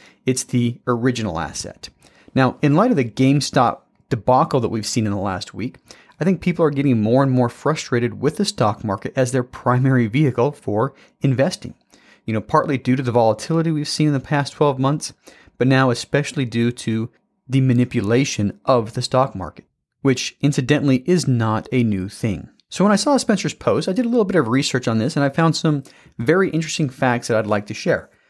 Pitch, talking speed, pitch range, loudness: 130 Hz, 205 wpm, 120-150 Hz, -19 LUFS